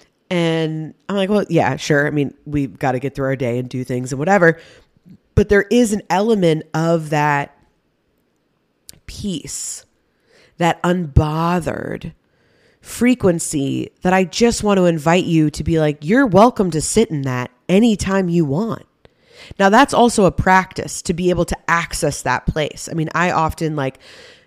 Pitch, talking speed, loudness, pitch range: 165 Hz, 165 wpm, -17 LUFS, 145-190 Hz